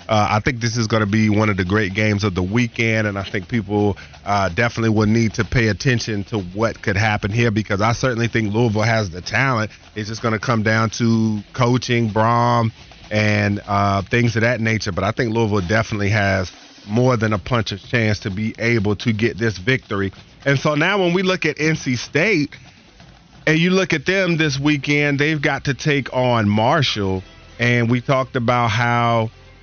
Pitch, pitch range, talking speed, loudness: 115 Hz, 105-125 Hz, 205 wpm, -19 LUFS